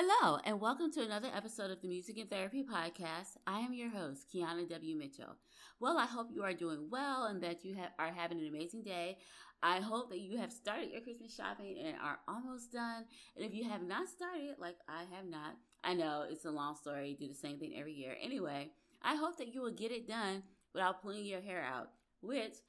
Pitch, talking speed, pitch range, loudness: 195 Hz, 225 wpm, 170-240 Hz, -42 LUFS